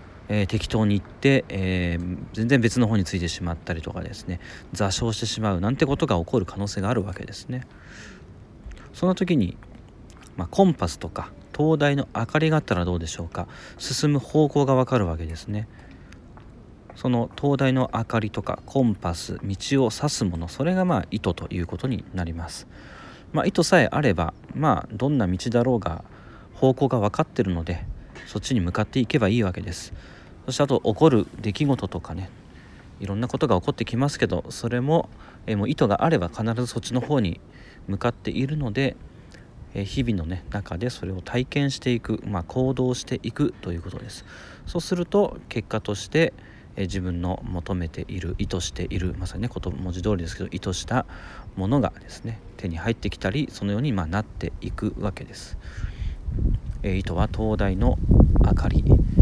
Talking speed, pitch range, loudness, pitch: 360 characters per minute, 90-125 Hz, -25 LUFS, 105 Hz